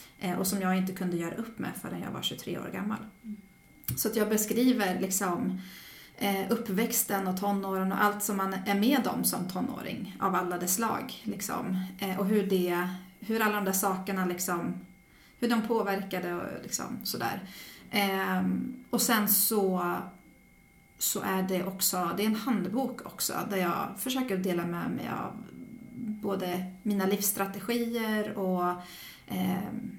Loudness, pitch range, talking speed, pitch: -30 LUFS, 185-220 Hz, 155 wpm, 195 Hz